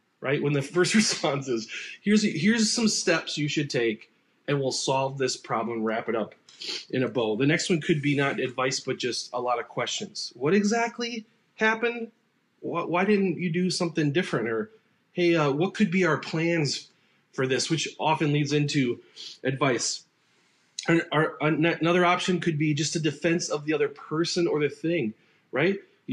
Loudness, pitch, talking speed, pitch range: -26 LUFS, 165 Hz, 180 wpm, 145-190 Hz